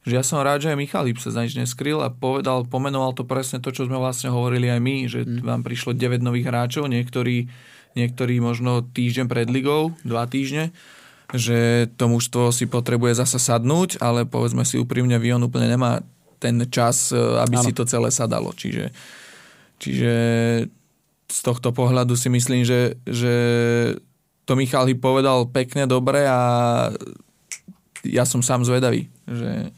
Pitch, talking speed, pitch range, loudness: 125 Hz, 150 wpm, 120-130 Hz, -21 LUFS